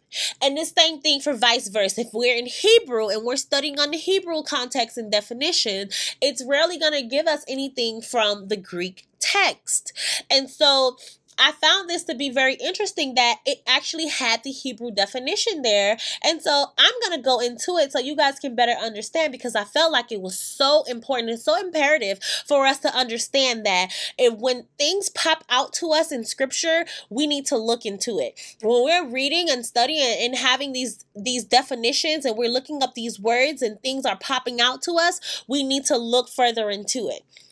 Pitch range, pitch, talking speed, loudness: 235-300 Hz, 265 Hz, 195 wpm, -21 LUFS